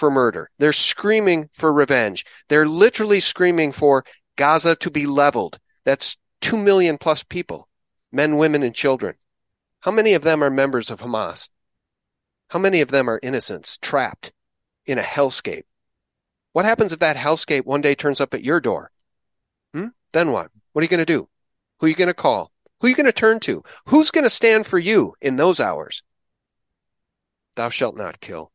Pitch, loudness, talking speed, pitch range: 155 Hz, -19 LUFS, 185 wpm, 140-185 Hz